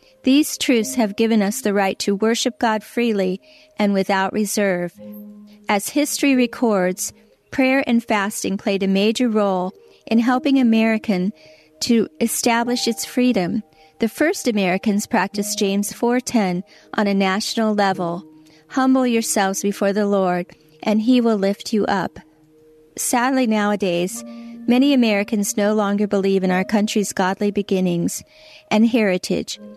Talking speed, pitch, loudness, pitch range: 135 wpm, 210 Hz, -19 LUFS, 195-235 Hz